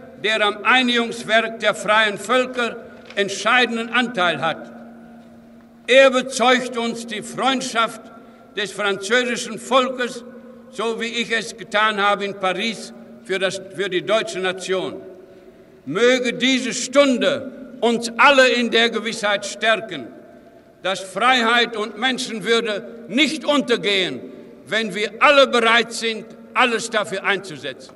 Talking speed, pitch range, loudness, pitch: 115 wpm, 205-245 Hz, -19 LUFS, 230 Hz